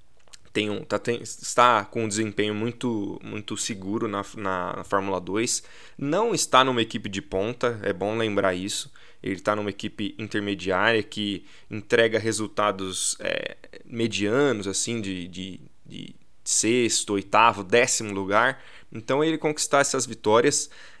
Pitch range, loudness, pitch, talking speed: 100-115 Hz, -24 LUFS, 105 Hz, 125 wpm